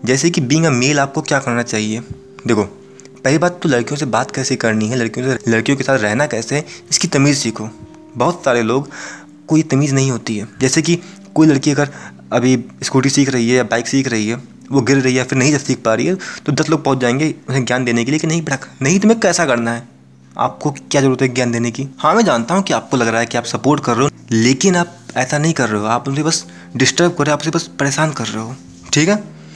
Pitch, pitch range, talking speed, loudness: 135 Hz, 120-150 Hz, 255 wpm, -16 LUFS